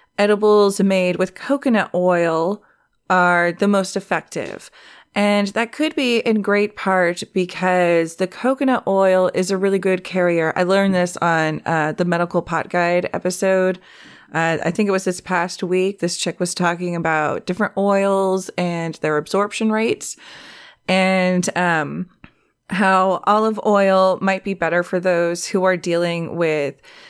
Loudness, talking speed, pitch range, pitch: -19 LUFS, 150 wpm, 175-200 Hz, 185 Hz